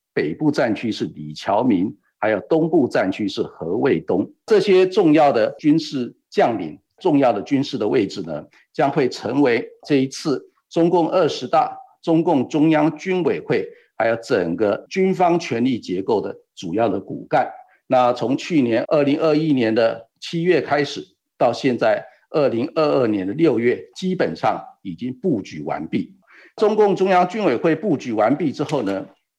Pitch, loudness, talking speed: 175 Hz, -20 LUFS, 245 characters per minute